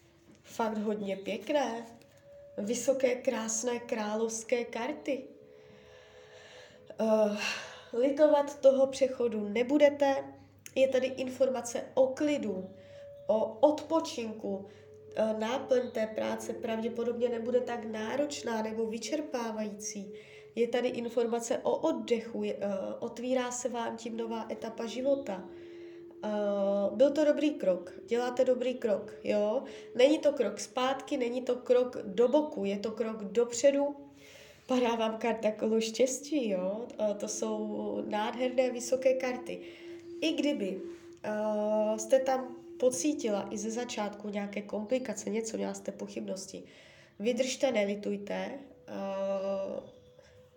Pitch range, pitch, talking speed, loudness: 210-265 Hz, 235 Hz, 110 wpm, -32 LUFS